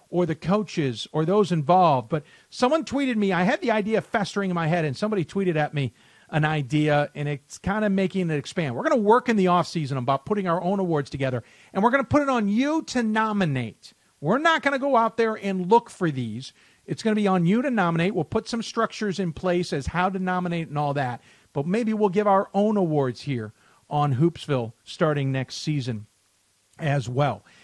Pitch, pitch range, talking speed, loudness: 175 Hz, 145-210 Hz, 220 wpm, -24 LUFS